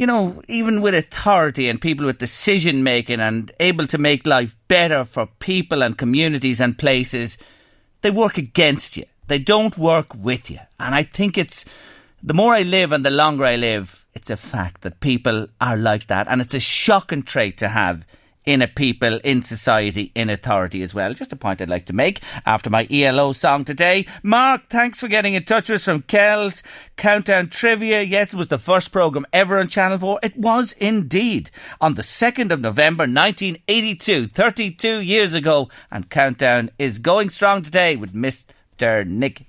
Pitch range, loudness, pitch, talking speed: 120-200 Hz, -18 LUFS, 155 Hz, 185 wpm